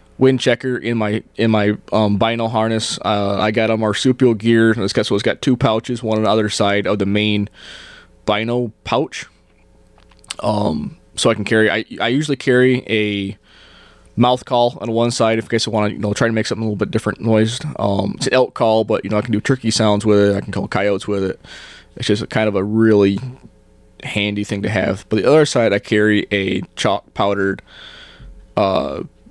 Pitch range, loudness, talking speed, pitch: 105-115 Hz, -17 LUFS, 215 wpm, 110 Hz